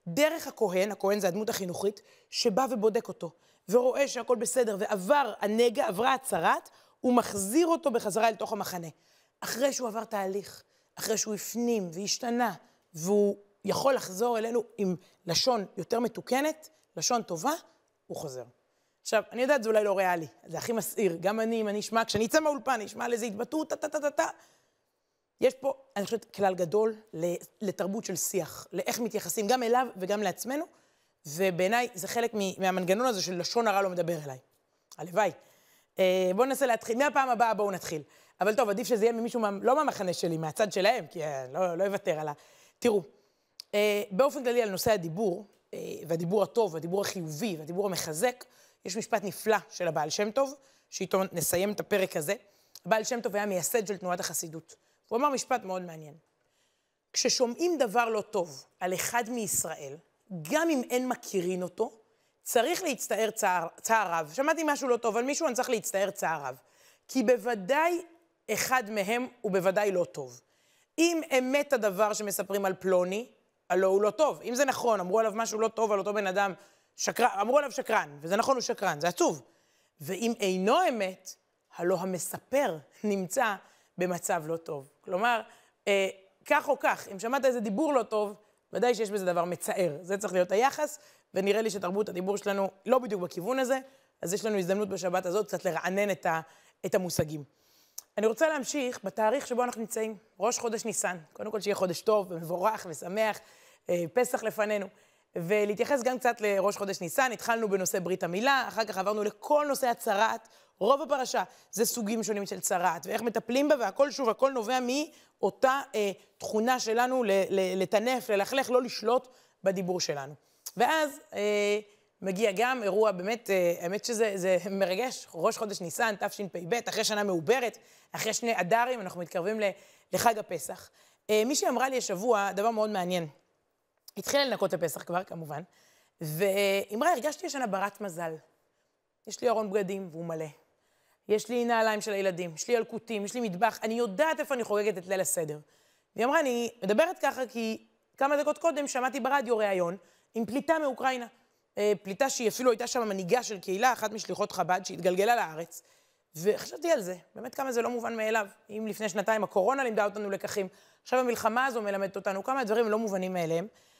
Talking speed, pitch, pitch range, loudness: 165 wpm, 215 Hz, 190-245 Hz, -29 LUFS